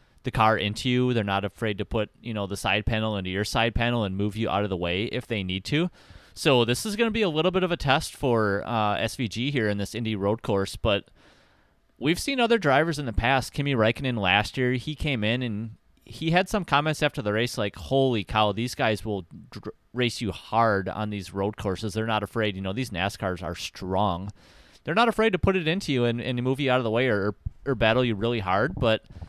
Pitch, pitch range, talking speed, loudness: 115 Hz, 100-130 Hz, 245 wpm, -26 LUFS